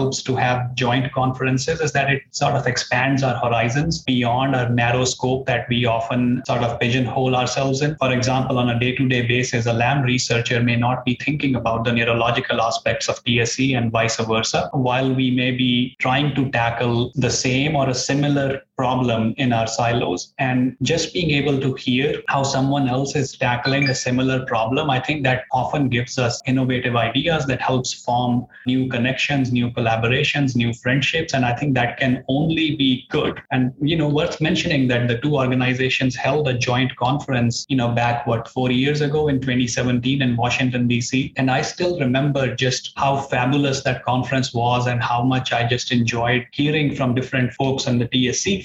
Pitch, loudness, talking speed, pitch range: 130 Hz, -20 LUFS, 185 wpm, 120-135 Hz